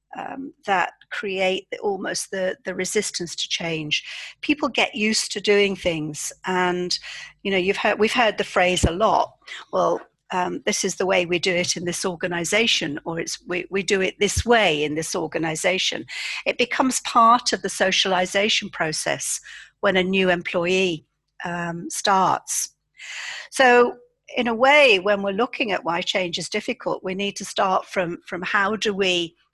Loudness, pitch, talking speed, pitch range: -21 LUFS, 195 Hz, 170 wpm, 180-220 Hz